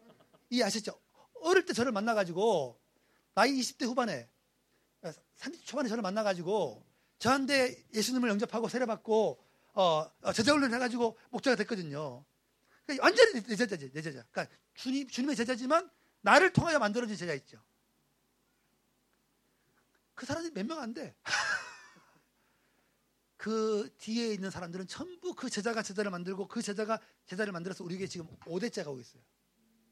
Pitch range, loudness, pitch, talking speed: 195-255 Hz, -32 LUFS, 225 Hz, 320 characters per minute